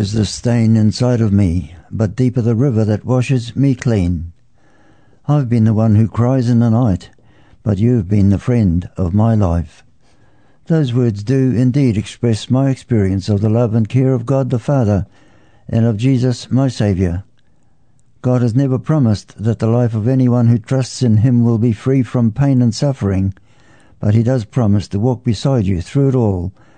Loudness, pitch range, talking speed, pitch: -15 LUFS, 105-130 Hz, 185 wpm, 115 Hz